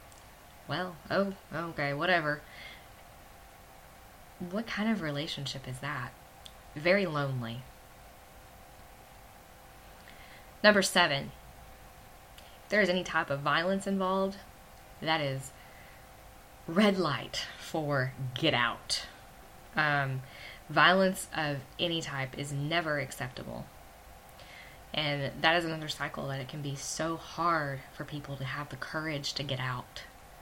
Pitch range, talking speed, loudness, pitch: 100-165 Hz, 110 wpm, -31 LUFS, 140 Hz